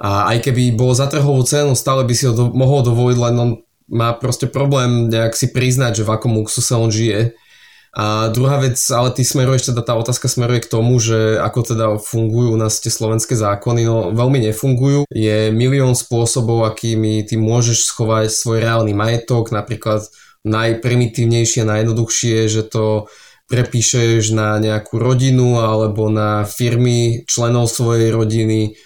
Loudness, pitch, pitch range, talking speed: -15 LUFS, 115 Hz, 110-125 Hz, 160 wpm